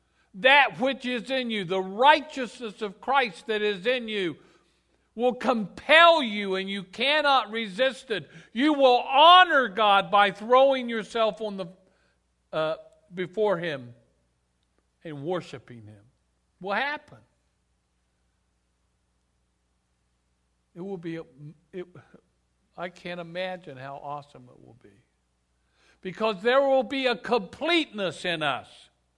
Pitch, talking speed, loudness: 185 Hz, 120 wpm, -23 LUFS